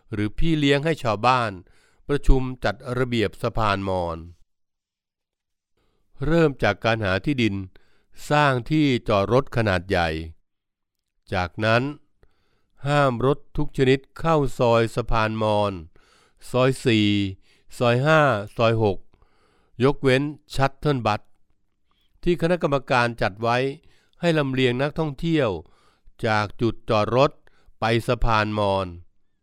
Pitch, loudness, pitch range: 115 Hz, -22 LUFS, 100-140 Hz